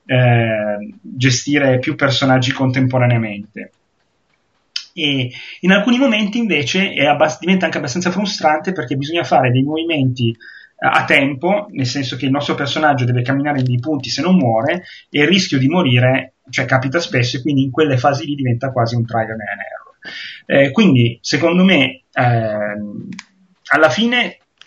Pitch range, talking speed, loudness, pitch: 125-160 Hz, 155 wpm, -15 LUFS, 140 Hz